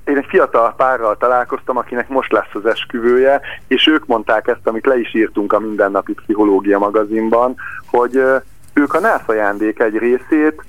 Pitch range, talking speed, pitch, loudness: 110-155 Hz, 165 wpm, 130 Hz, -15 LUFS